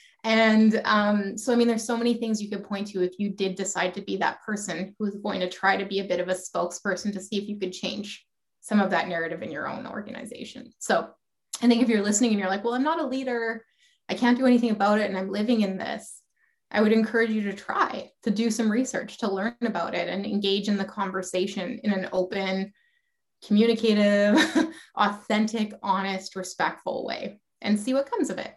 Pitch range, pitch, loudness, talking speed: 195-235 Hz, 210 Hz, -26 LUFS, 220 wpm